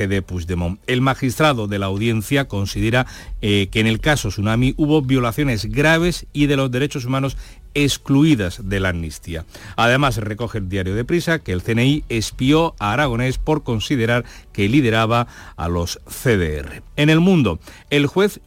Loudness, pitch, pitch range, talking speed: -19 LUFS, 120 Hz, 100-145 Hz, 160 wpm